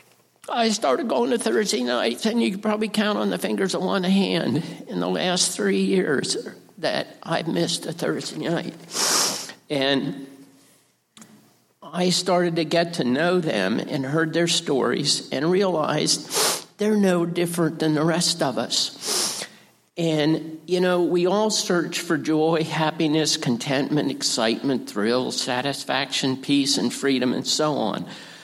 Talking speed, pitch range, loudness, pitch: 145 wpm, 150-190 Hz, -22 LUFS, 170 Hz